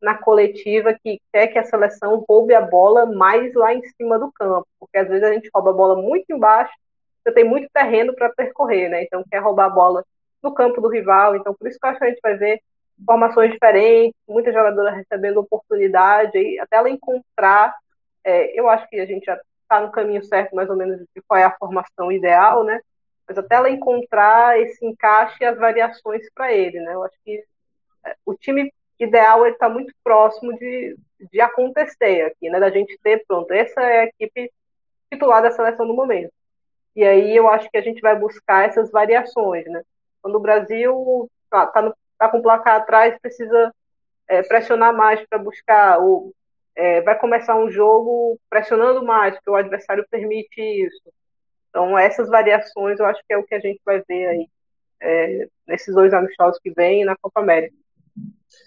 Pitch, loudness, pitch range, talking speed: 220 Hz, -16 LUFS, 200-235 Hz, 195 wpm